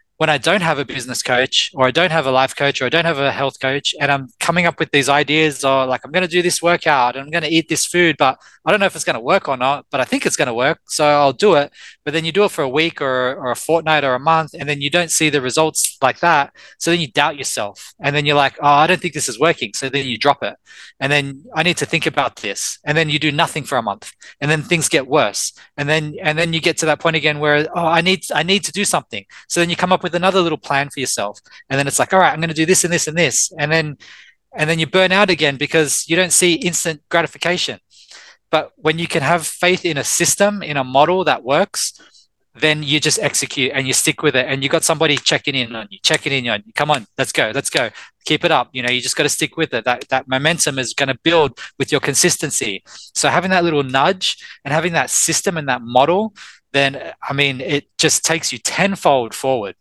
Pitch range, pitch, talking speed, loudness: 140-170 Hz, 155 Hz, 270 wpm, -16 LUFS